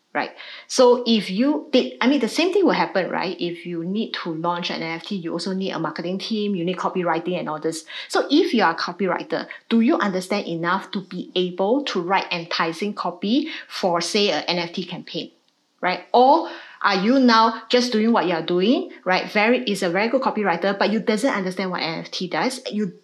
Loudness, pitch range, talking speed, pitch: -21 LUFS, 175-230 Hz, 210 wpm, 195 Hz